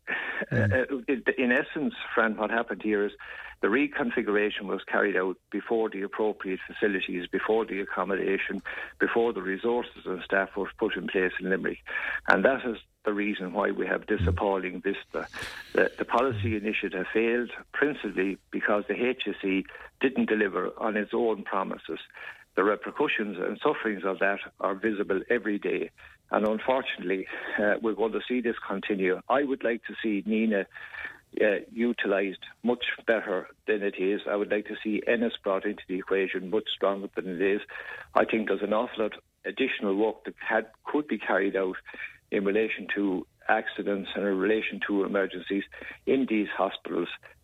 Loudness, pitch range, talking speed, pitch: -28 LUFS, 100-115 Hz, 165 wpm, 105 Hz